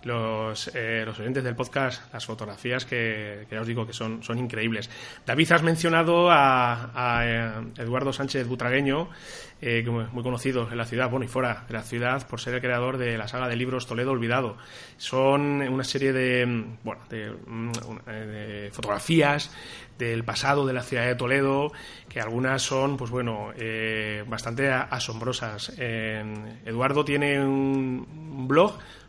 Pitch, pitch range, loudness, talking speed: 125 Hz, 115-135 Hz, -26 LUFS, 155 wpm